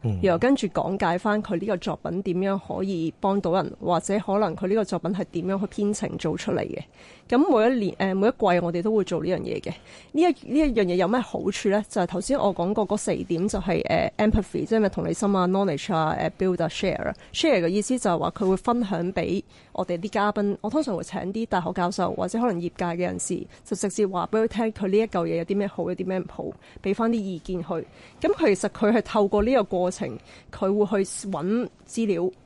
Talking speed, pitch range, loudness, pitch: 395 characters per minute, 180-215 Hz, -25 LUFS, 195 Hz